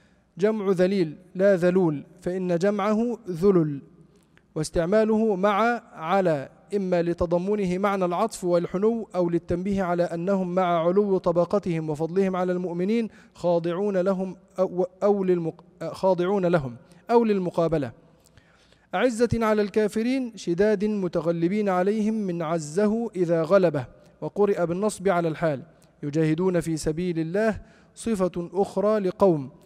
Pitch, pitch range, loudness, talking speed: 185 Hz, 170-205 Hz, -24 LUFS, 110 wpm